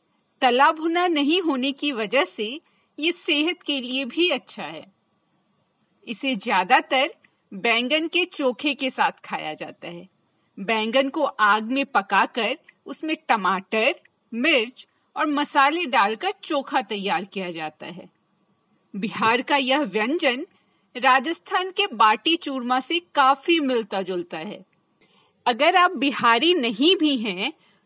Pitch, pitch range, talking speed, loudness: 275 Hz, 225-315 Hz, 125 wpm, -22 LUFS